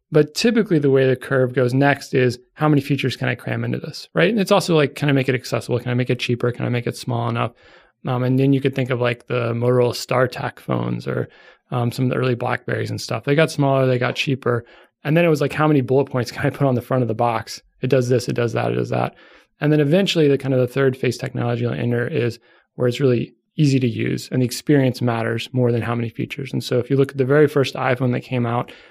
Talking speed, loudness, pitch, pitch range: 275 wpm, -20 LUFS, 130 Hz, 120-140 Hz